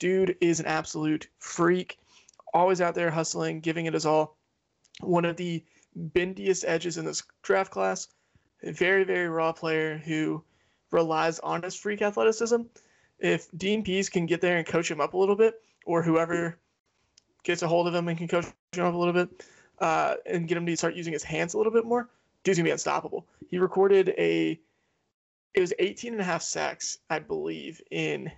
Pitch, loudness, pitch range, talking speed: 170 Hz, -27 LUFS, 160-190 Hz, 195 wpm